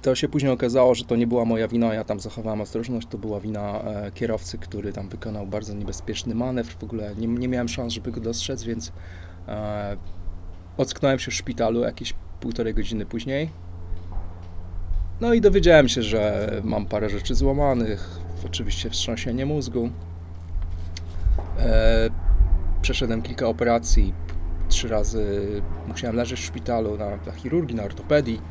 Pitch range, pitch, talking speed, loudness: 85-115 Hz, 105 Hz, 150 wpm, -25 LUFS